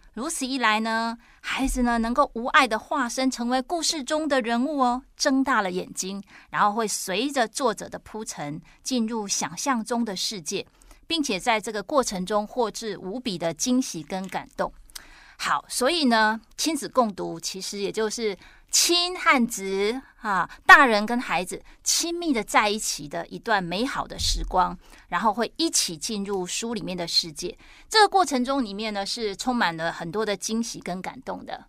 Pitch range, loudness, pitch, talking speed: 195-260 Hz, -24 LUFS, 225 Hz, 255 characters per minute